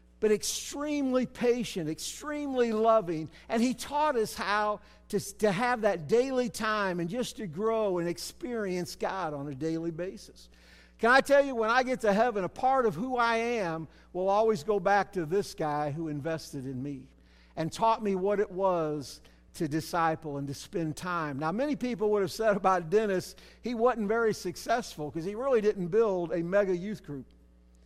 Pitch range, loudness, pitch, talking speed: 160-225 Hz, -29 LUFS, 200 Hz, 185 wpm